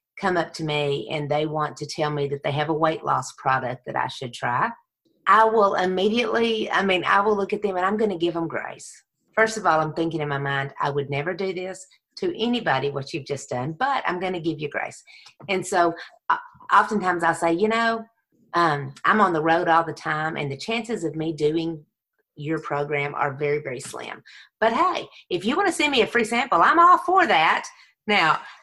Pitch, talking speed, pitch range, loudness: 170 Hz, 225 wpm, 150-220 Hz, -23 LUFS